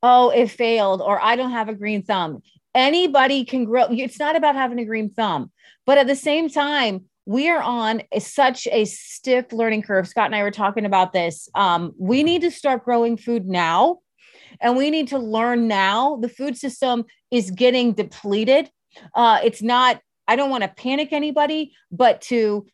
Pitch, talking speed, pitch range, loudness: 240 Hz, 190 wpm, 215-270 Hz, -20 LUFS